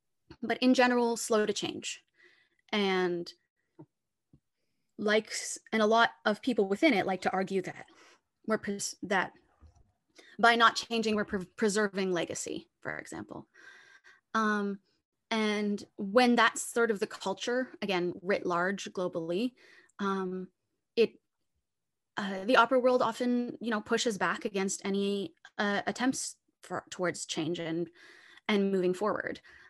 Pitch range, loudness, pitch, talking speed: 190-235 Hz, -30 LUFS, 210 Hz, 130 wpm